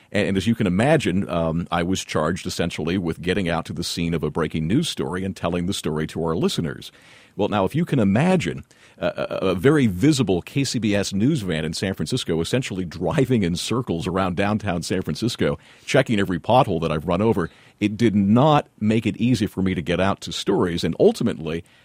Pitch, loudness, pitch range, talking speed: 95 Hz, -22 LUFS, 85-110 Hz, 205 wpm